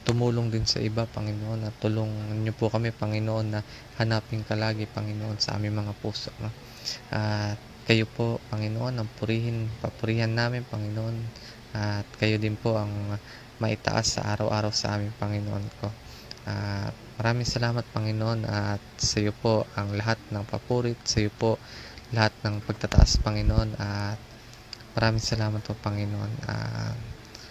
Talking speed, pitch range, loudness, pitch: 145 wpm, 105-115 Hz, -28 LUFS, 110 Hz